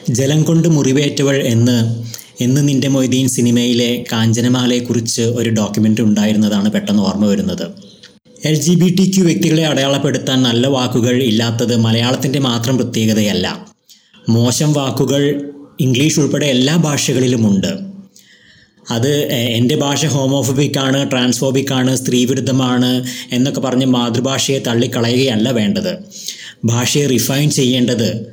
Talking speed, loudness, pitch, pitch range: 105 wpm, -14 LUFS, 130 Hz, 120-145 Hz